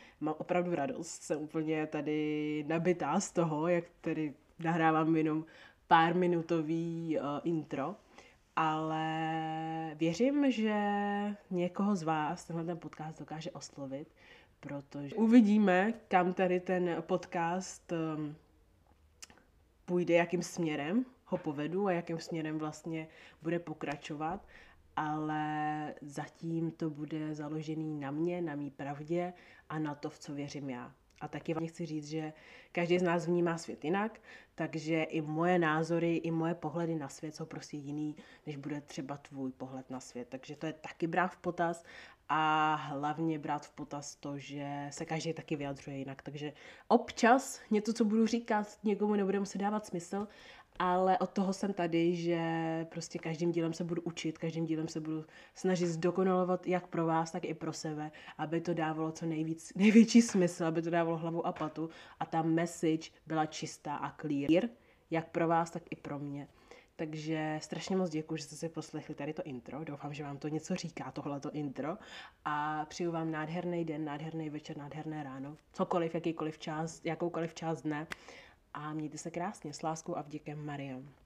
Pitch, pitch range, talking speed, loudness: 160 Hz, 150-175 Hz, 160 wpm, -35 LUFS